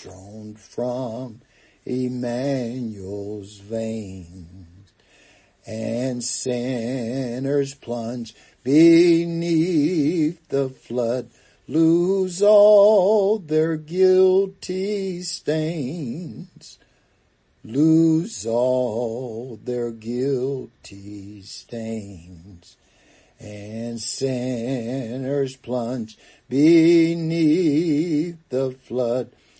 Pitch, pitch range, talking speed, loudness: 130 Hz, 115-165 Hz, 55 wpm, -21 LUFS